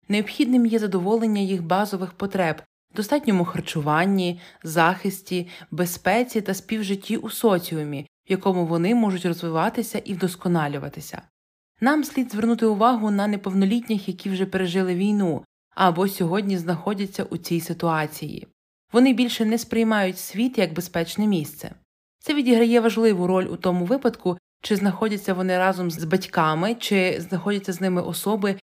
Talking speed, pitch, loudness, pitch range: 130 wpm, 195 Hz, -23 LUFS, 180-220 Hz